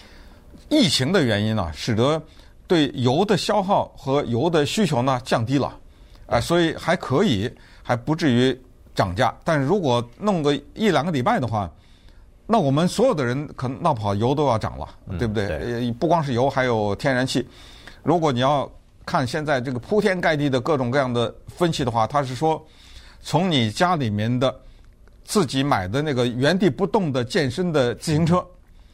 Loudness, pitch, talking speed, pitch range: -22 LUFS, 130 Hz, 260 characters per minute, 120-160 Hz